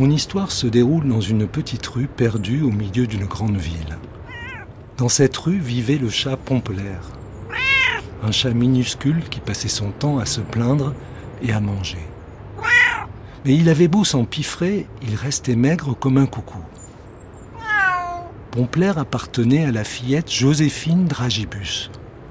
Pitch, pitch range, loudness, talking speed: 125 Hz, 105-140 Hz, -19 LUFS, 140 wpm